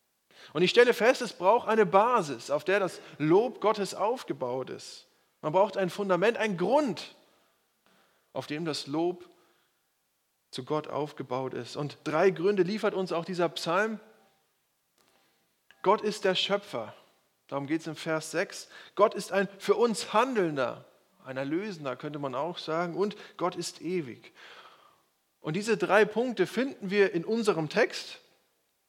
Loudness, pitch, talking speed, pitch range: -29 LUFS, 185 Hz, 150 wpm, 160-210 Hz